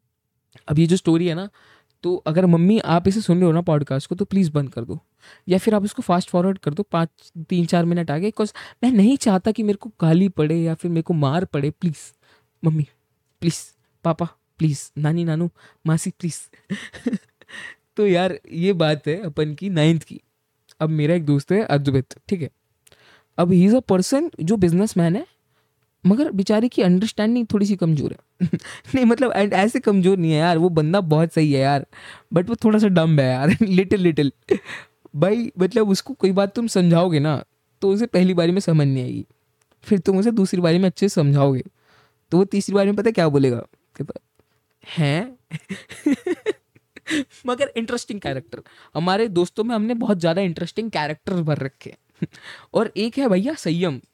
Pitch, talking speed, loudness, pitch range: 180 Hz, 185 wpm, -20 LUFS, 160-205 Hz